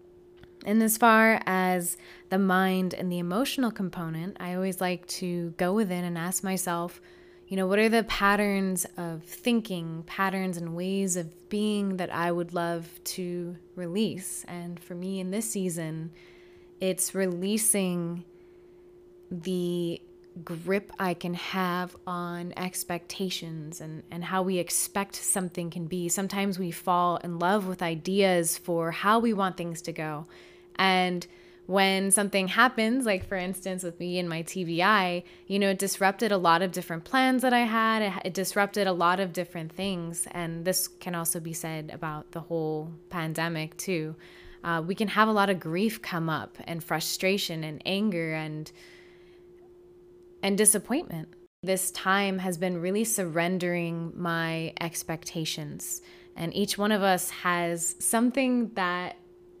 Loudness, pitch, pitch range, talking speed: -28 LUFS, 180 Hz, 175-200 Hz, 150 wpm